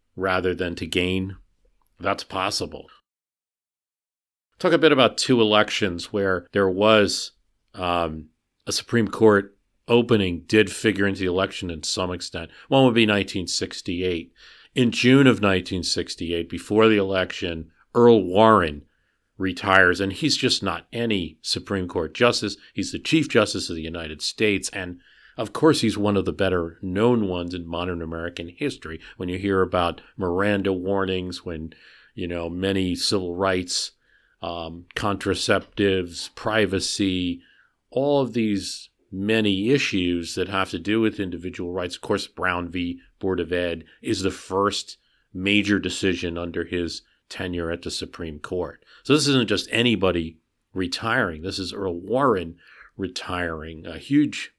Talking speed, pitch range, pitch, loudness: 145 wpm, 85-105 Hz, 95 Hz, -23 LUFS